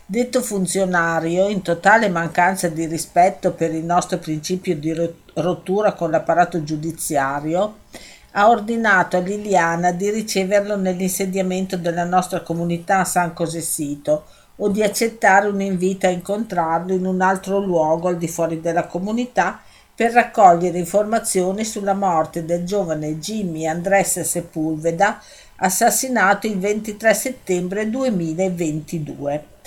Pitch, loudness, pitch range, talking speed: 185 Hz, -19 LUFS, 170-200 Hz, 120 wpm